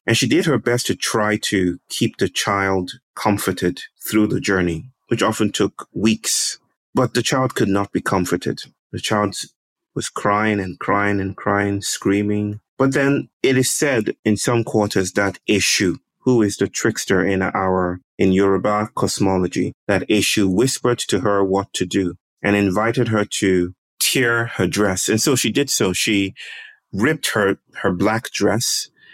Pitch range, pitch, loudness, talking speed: 95-115 Hz, 100 Hz, -19 LUFS, 165 wpm